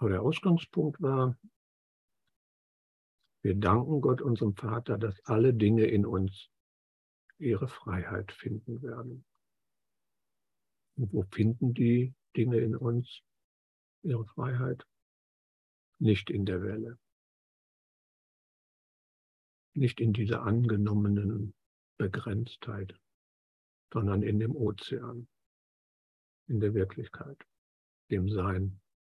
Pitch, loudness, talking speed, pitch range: 105 Hz, -31 LUFS, 95 wpm, 95-120 Hz